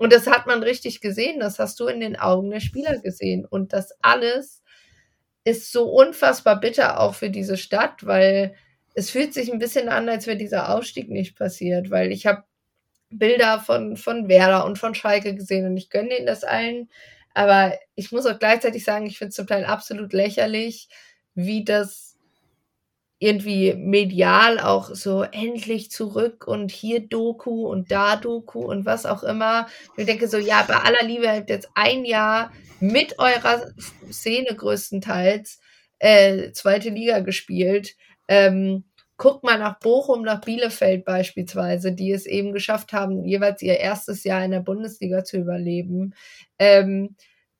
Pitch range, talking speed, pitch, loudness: 195-230 Hz, 165 wpm, 210 Hz, -20 LUFS